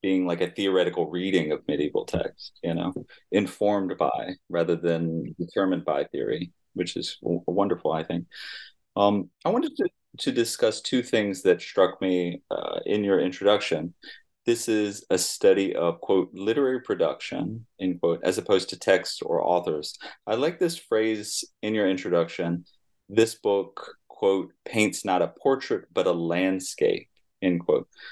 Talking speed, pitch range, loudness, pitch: 155 wpm, 90-110 Hz, -26 LUFS, 100 Hz